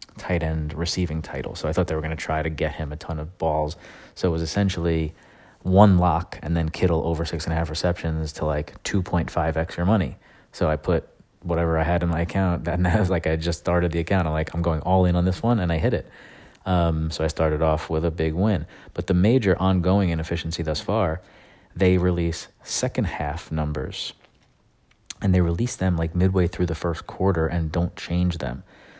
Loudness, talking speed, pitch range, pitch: -24 LUFS, 215 wpm, 80-95 Hz, 85 Hz